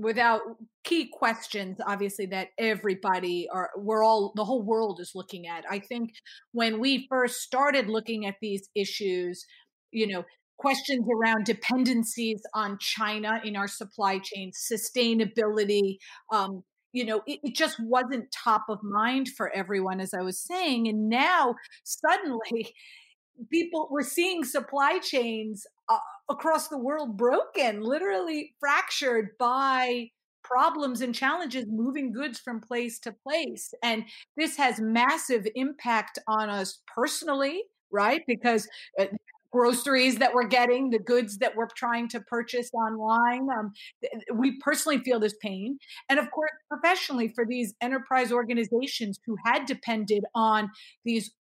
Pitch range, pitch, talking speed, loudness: 215-265 Hz, 235 Hz, 140 wpm, -27 LUFS